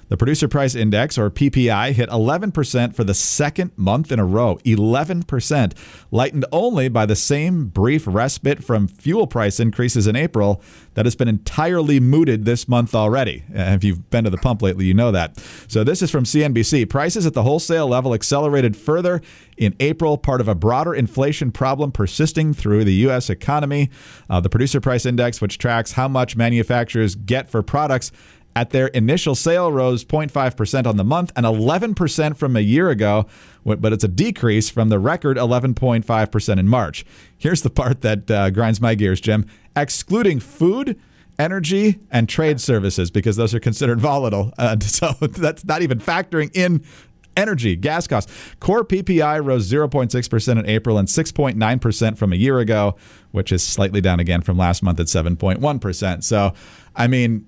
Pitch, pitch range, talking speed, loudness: 120 Hz, 105-145 Hz, 170 wpm, -18 LUFS